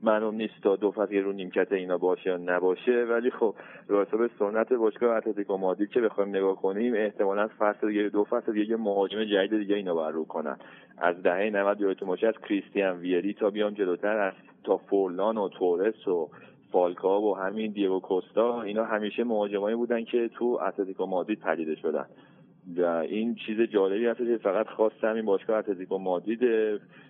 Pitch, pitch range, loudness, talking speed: 105 Hz, 95-110 Hz, -28 LUFS, 180 wpm